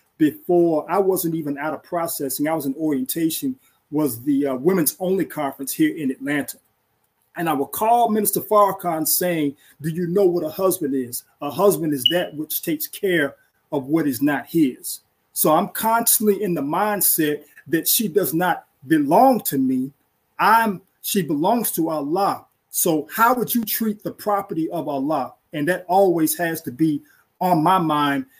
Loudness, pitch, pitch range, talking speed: -21 LUFS, 175 Hz, 150-215 Hz, 175 wpm